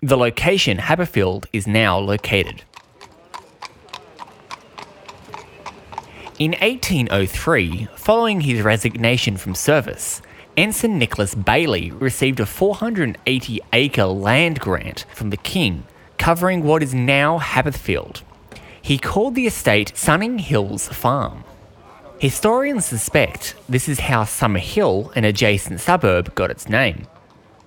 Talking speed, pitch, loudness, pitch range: 110 wpm, 125 Hz, -18 LUFS, 105-155 Hz